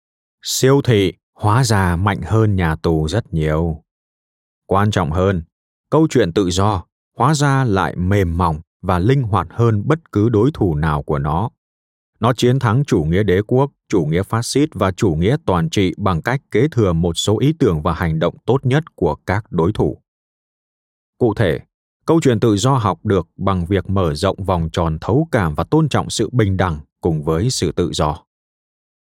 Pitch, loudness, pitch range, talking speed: 100 Hz, -17 LUFS, 85-120 Hz, 190 wpm